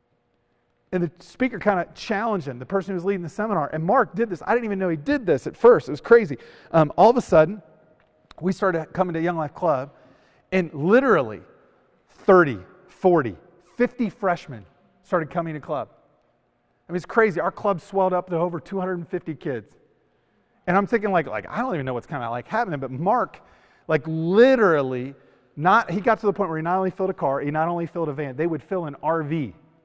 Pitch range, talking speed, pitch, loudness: 160-200 Hz, 215 wpm, 180 Hz, -22 LUFS